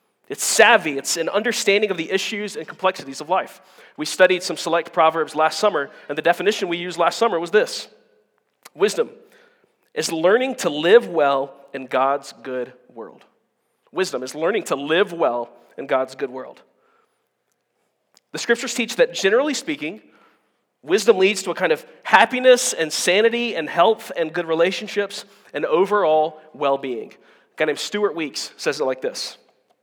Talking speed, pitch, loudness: 165 wpm, 200 Hz, -20 LUFS